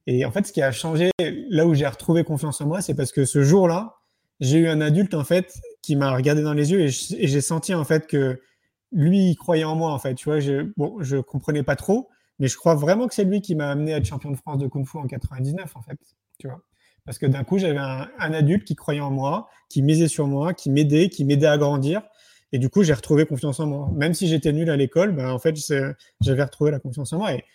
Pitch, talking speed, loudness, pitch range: 150 Hz, 270 wpm, -22 LUFS, 140-165 Hz